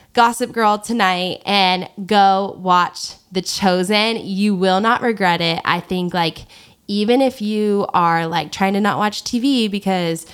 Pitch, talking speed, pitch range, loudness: 195 Hz, 155 wpm, 180-210 Hz, -17 LUFS